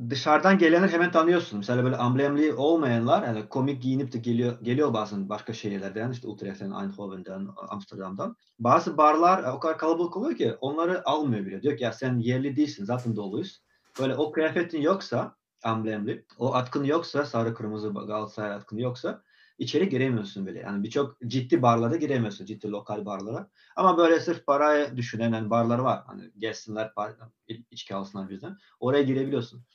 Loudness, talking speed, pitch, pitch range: -26 LUFS, 160 wpm, 120 Hz, 110-150 Hz